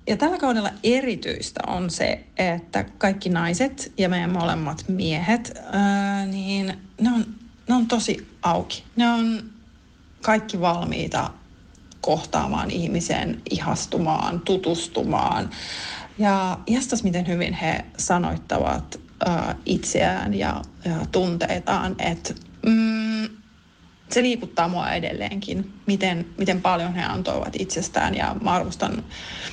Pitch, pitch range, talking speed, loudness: 195 Hz, 175-225 Hz, 110 wpm, -24 LUFS